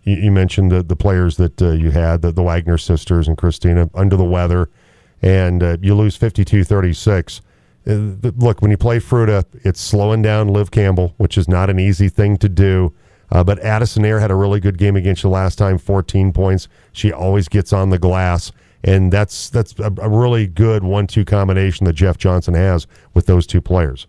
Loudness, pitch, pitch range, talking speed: -15 LUFS, 95 Hz, 90-105 Hz, 195 wpm